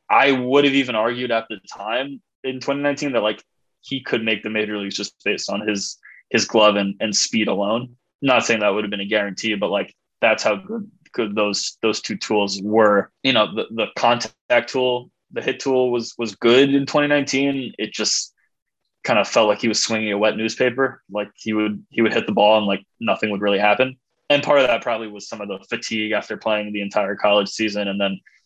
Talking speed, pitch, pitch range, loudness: 220 wpm, 110 Hz, 105-130 Hz, -20 LUFS